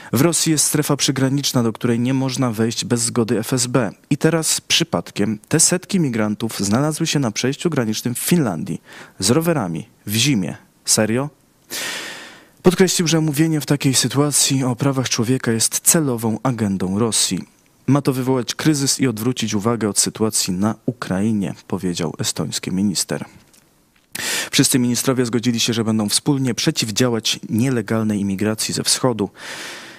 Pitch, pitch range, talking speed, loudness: 125 Hz, 110-145 Hz, 140 wpm, -18 LUFS